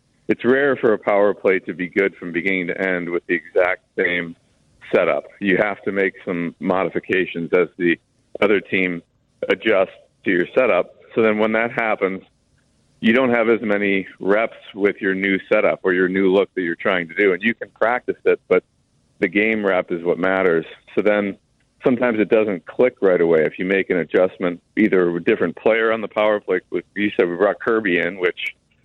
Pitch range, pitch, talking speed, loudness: 90-105 Hz, 95 Hz, 205 wpm, -19 LUFS